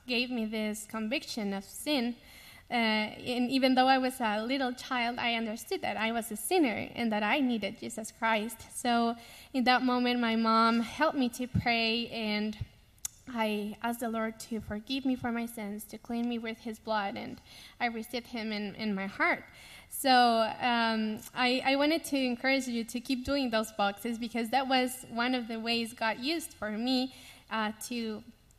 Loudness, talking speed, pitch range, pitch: -31 LUFS, 185 wpm, 220-255 Hz, 235 Hz